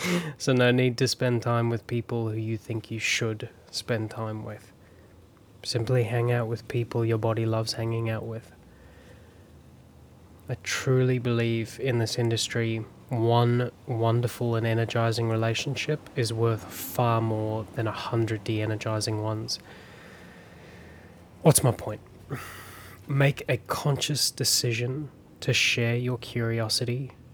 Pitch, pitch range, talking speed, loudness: 115 Hz, 110-120 Hz, 130 wpm, -27 LUFS